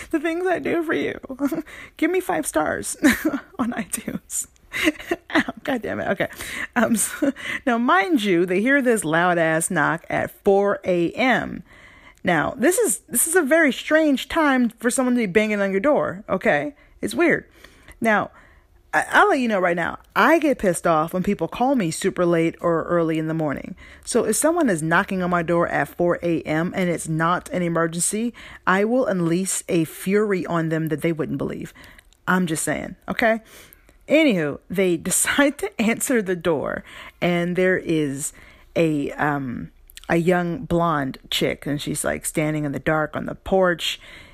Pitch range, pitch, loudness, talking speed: 170-270 Hz, 190 Hz, -21 LUFS, 175 wpm